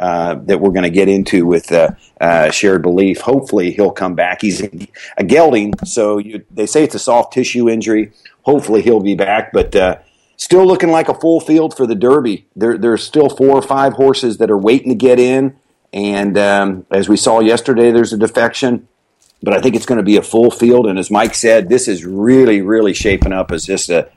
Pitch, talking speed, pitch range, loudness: 115 Hz, 220 wpm, 100-130 Hz, -12 LUFS